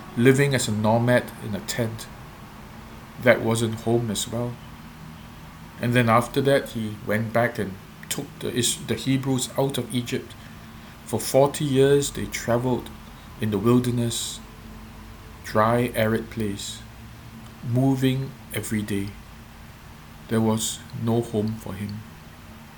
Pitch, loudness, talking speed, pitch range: 115 Hz, -24 LUFS, 125 wpm, 110-125 Hz